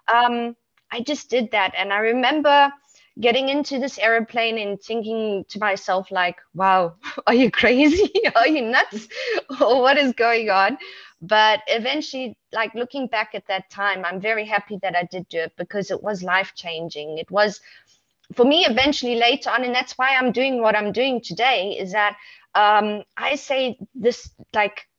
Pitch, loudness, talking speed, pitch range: 225 Hz, -20 LUFS, 175 wpm, 200-255 Hz